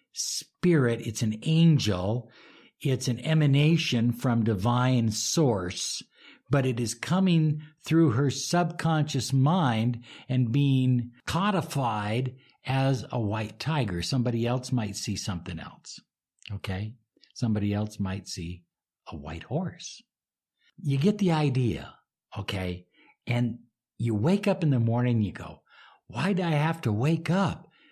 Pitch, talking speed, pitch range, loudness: 125 Hz, 130 wpm, 110-155 Hz, -27 LUFS